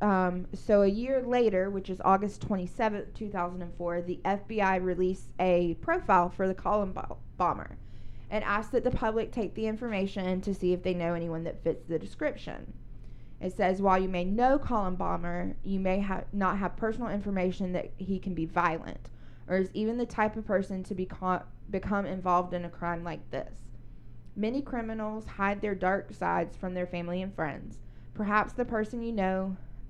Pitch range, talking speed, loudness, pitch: 175-210 Hz, 180 wpm, -31 LUFS, 190 Hz